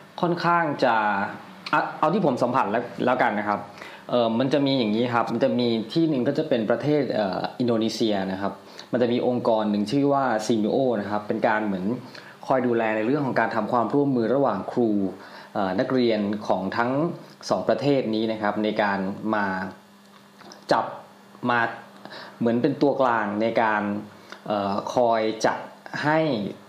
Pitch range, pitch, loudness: 105-130 Hz, 115 Hz, -24 LUFS